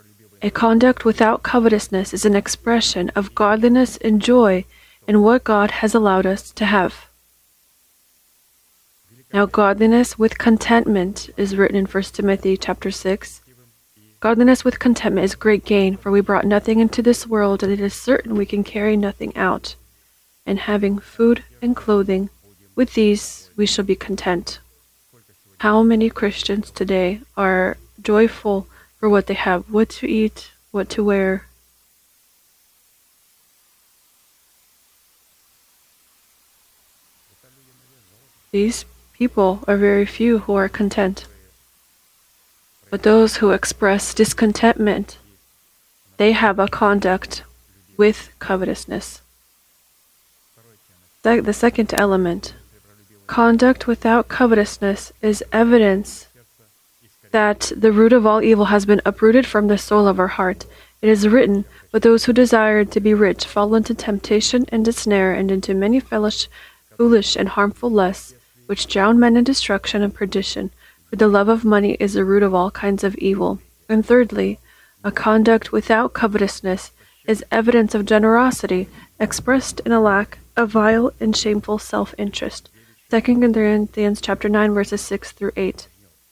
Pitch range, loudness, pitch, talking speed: 190-225 Hz, -17 LUFS, 205 Hz, 135 wpm